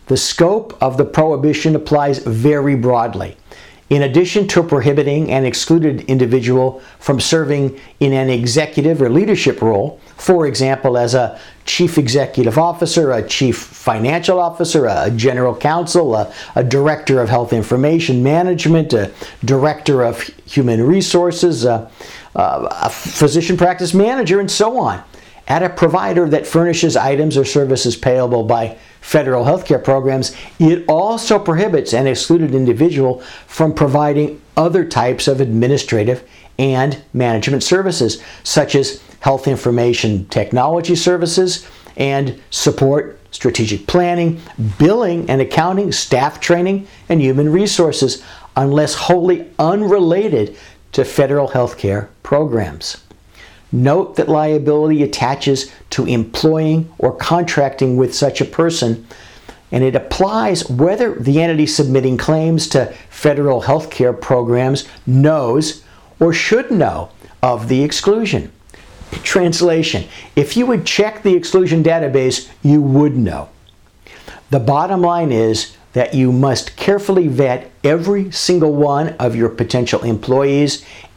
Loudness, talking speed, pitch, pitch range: -15 LUFS, 125 wpm, 145 Hz, 125-165 Hz